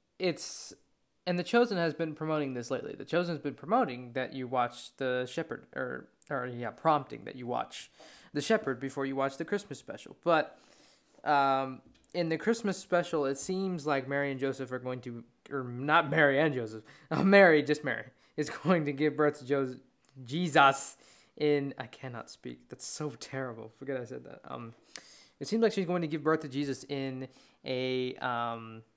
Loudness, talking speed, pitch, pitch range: -31 LUFS, 190 wpm, 140 Hz, 130-160 Hz